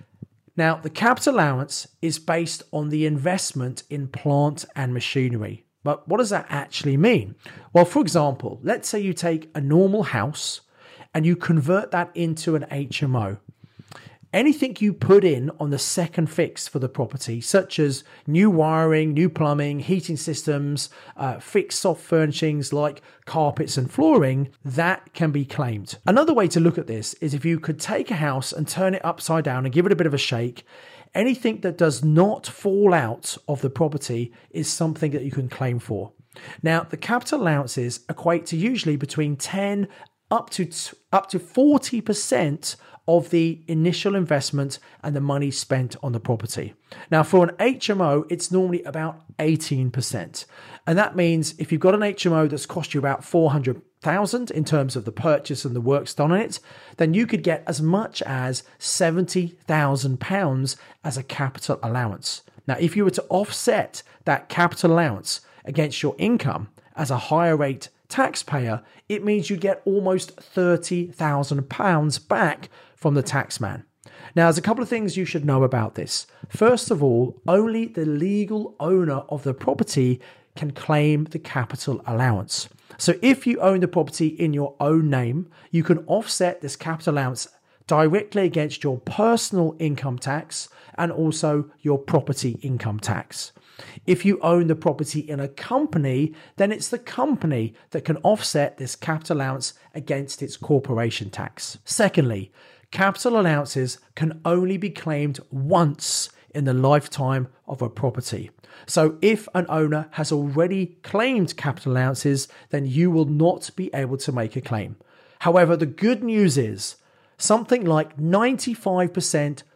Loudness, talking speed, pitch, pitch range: -22 LUFS, 160 wpm, 155 Hz, 135-180 Hz